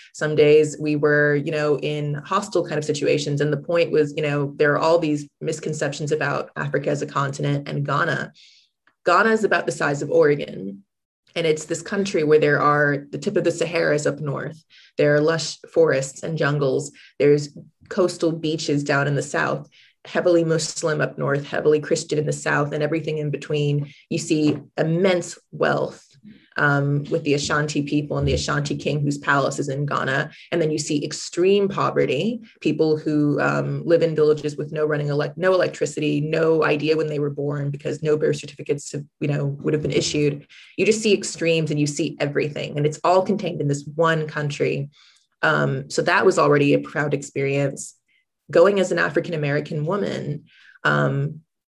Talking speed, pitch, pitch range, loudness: 185 wpm, 150 Hz, 145-165 Hz, -21 LUFS